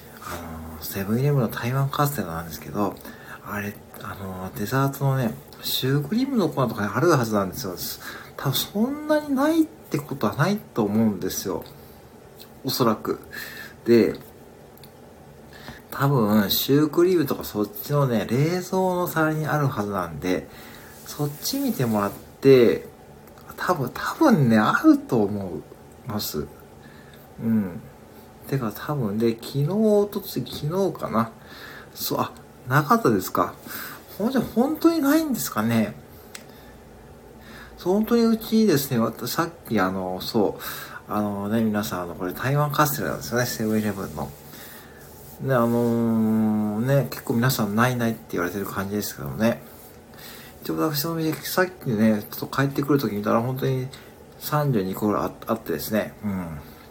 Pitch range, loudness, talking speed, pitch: 100-150 Hz, -24 LUFS, 290 characters per minute, 115 Hz